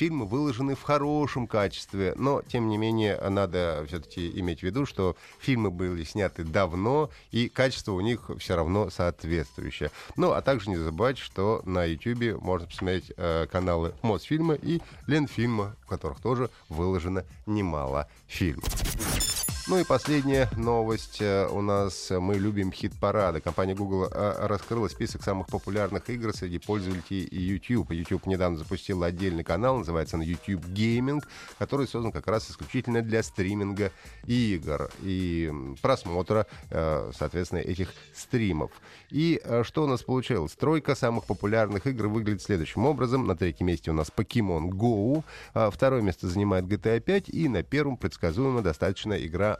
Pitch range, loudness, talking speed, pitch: 90-120 Hz, -28 LUFS, 145 wpm, 100 Hz